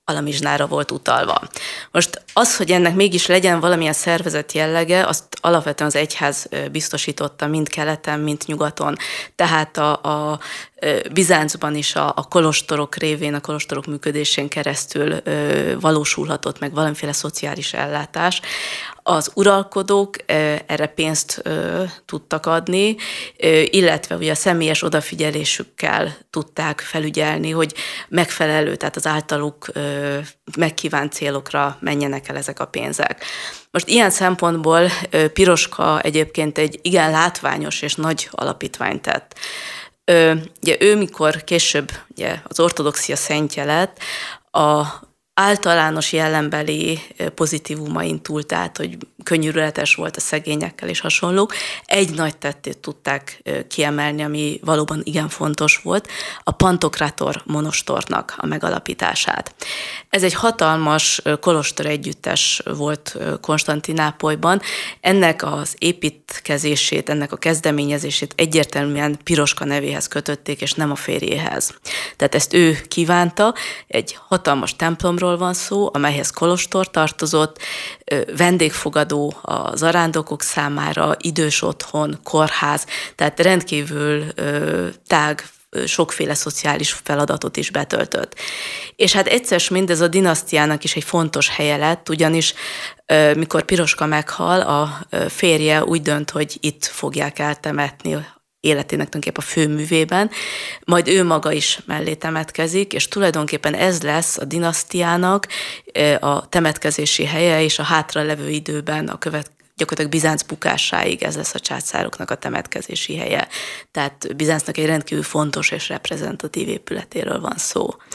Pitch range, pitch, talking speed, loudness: 150-170 Hz, 155 Hz, 120 wpm, -19 LUFS